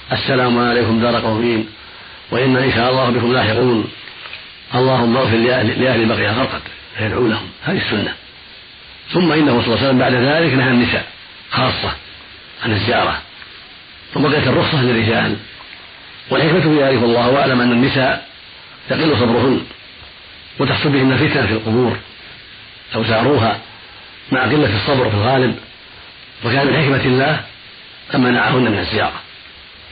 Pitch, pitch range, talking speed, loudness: 120 Hz, 115-130 Hz, 130 wpm, -15 LUFS